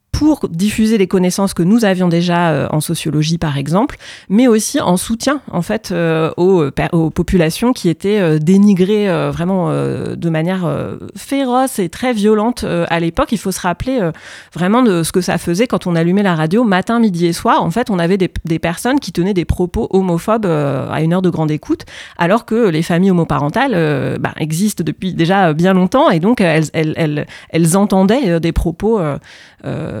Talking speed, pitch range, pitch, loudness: 205 wpm, 165-210 Hz, 180 Hz, -14 LUFS